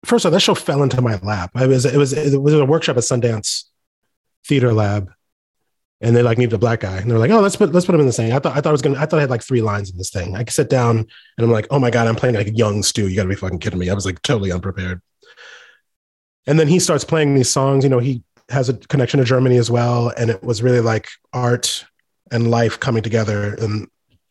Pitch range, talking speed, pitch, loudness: 110-140 Hz, 280 wpm, 120 Hz, -17 LUFS